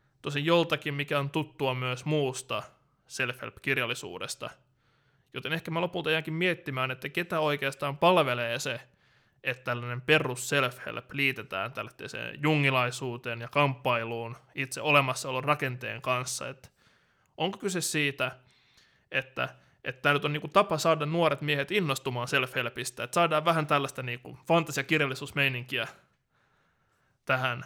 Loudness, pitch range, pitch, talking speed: -29 LUFS, 130-155 Hz, 140 Hz, 120 wpm